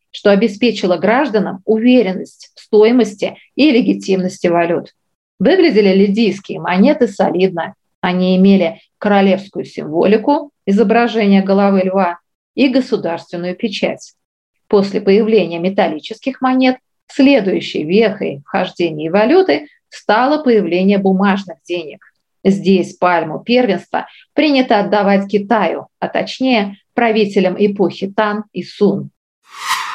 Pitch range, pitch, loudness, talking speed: 185-230 Hz, 205 Hz, -14 LUFS, 95 wpm